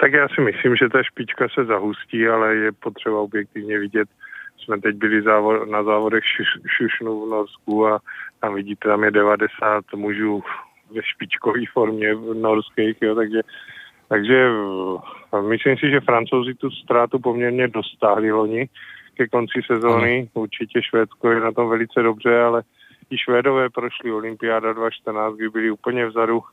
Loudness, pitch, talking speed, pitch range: -20 LUFS, 110 Hz, 150 wpm, 105-120 Hz